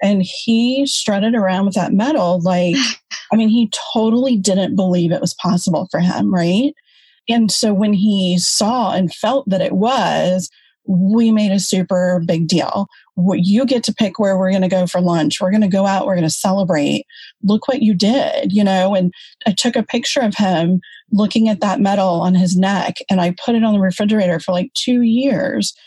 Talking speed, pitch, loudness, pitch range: 195 wpm, 195 Hz, -16 LUFS, 185-225 Hz